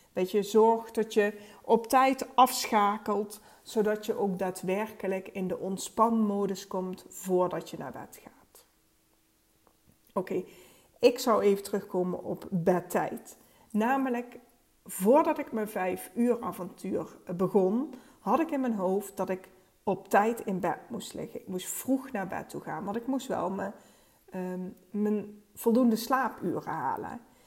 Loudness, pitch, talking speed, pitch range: -30 LUFS, 210 Hz, 145 wpm, 190-240 Hz